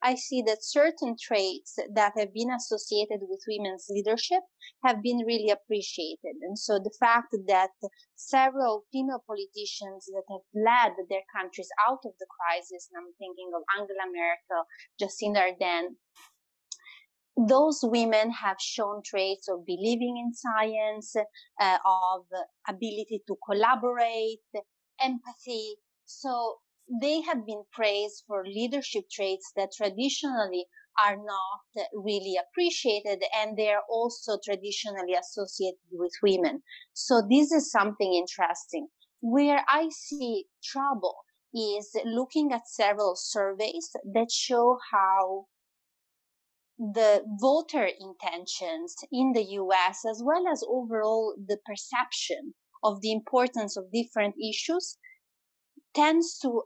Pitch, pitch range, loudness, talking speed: 215 Hz, 195-250 Hz, -28 LUFS, 120 wpm